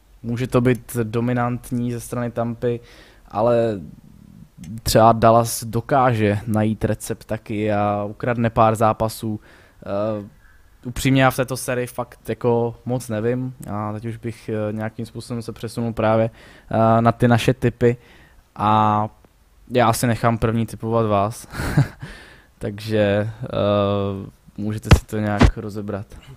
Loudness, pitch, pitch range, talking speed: -21 LUFS, 115 Hz, 105-120 Hz, 125 wpm